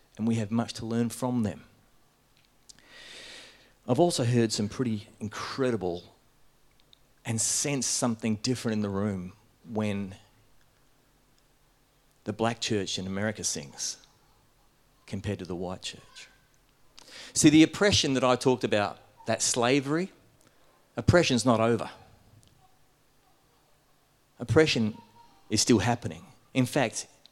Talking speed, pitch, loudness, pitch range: 110 wpm, 120 Hz, -27 LUFS, 110-135 Hz